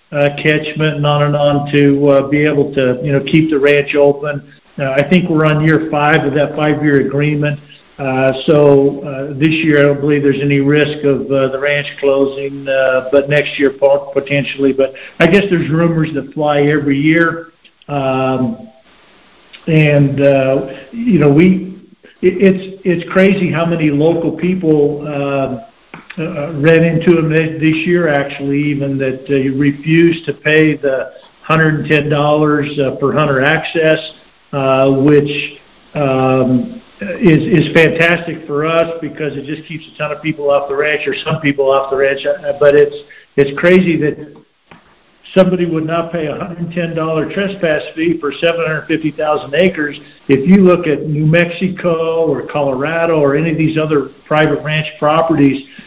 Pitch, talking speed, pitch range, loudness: 150 Hz, 165 wpm, 140-160 Hz, -13 LUFS